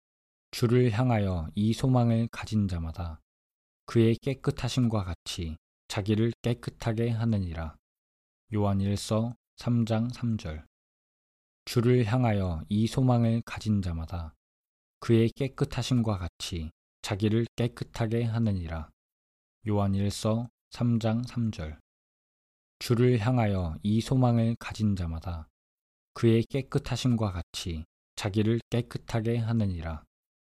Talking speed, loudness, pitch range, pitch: 220 characters per minute, -29 LUFS, 85-120 Hz, 110 Hz